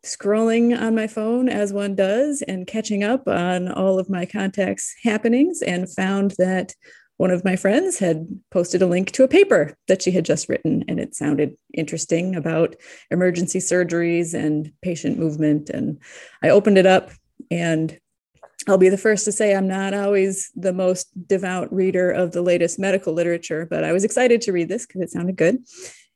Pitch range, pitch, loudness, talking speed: 175-205 Hz, 185 Hz, -20 LUFS, 185 wpm